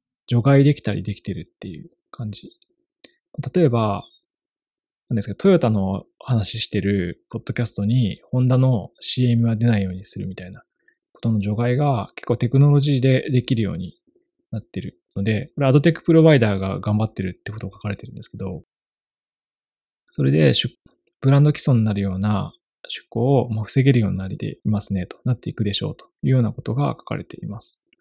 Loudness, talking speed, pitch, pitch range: -20 LUFS, 375 characters per minute, 120 Hz, 105-145 Hz